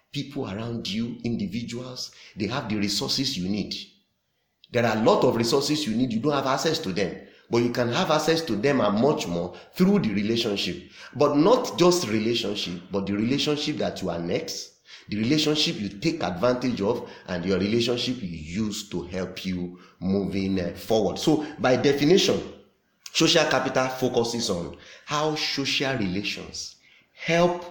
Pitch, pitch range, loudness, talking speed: 120 Hz, 100-150 Hz, -25 LUFS, 160 wpm